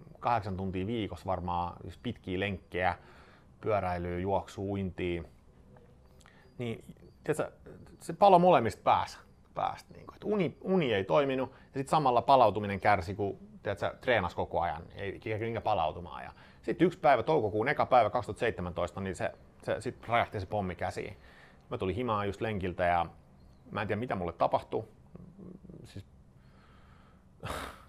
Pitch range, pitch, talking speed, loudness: 90-115 Hz, 95 Hz, 130 wpm, -31 LUFS